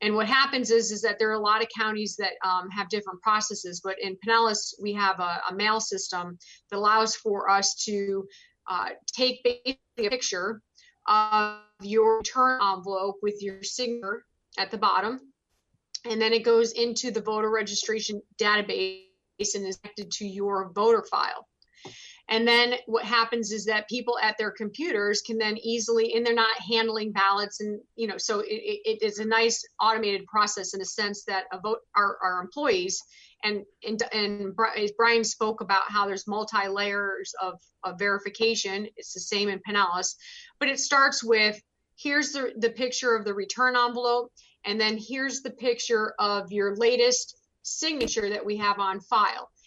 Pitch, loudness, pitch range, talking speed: 215 Hz, -26 LUFS, 205-235 Hz, 175 wpm